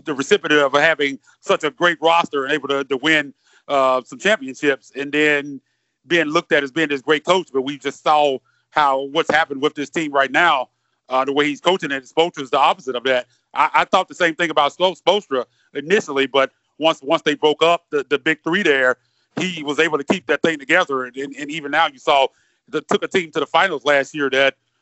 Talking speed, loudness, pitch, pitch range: 230 wpm, -18 LUFS, 145 Hz, 135-165 Hz